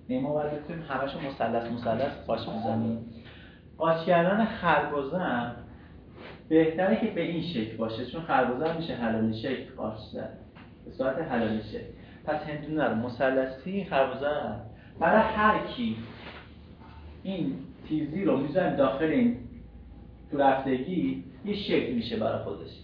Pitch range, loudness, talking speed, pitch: 115-165 Hz, -28 LUFS, 120 wpm, 135 Hz